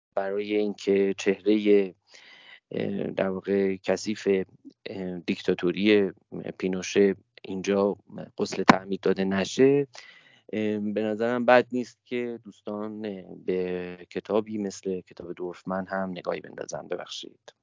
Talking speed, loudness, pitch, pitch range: 95 wpm, -27 LUFS, 100 Hz, 95-105 Hz